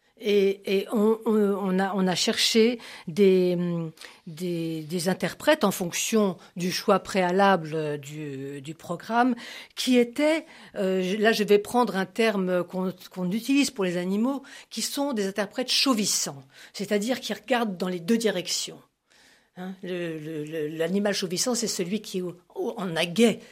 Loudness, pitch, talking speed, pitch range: -25 LUFS, 195 Hz, 155 wpm, 180-225 Hz